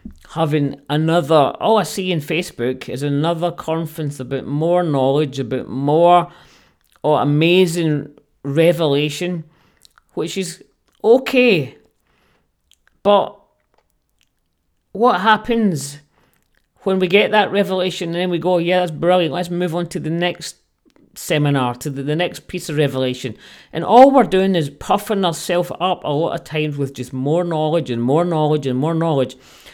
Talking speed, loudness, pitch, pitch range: 145 wpm, -17 LUFS, 165 Hz, 145-180 Hz